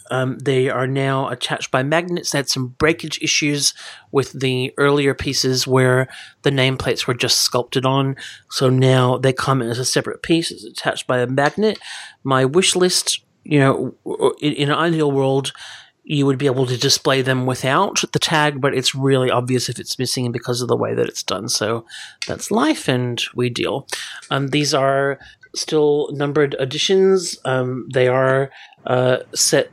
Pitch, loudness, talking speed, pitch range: 135 Hz, -18 LUFS, 180 wpm, 130-150 Hz